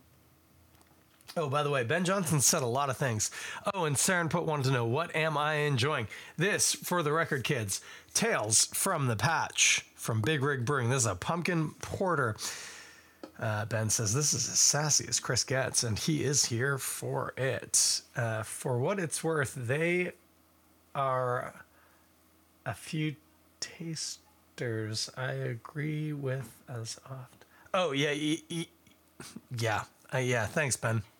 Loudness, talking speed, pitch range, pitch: -30 LUFS, 150 wpm, 110-155 Hz, 130 Hz